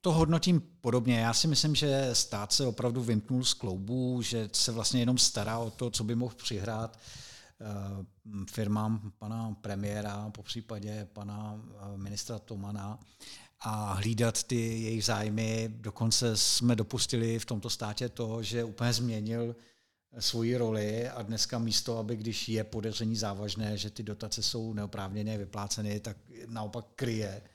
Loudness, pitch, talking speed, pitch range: -32 LUFS, 115 Hz, 145 wpm, 105-120 Hz